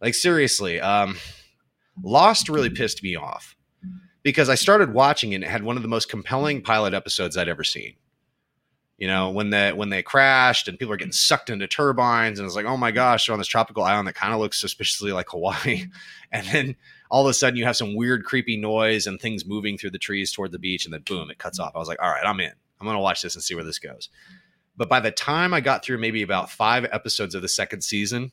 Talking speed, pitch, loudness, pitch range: 250 wpm, 120 Hz, -22 LUFS, 105-135 Hz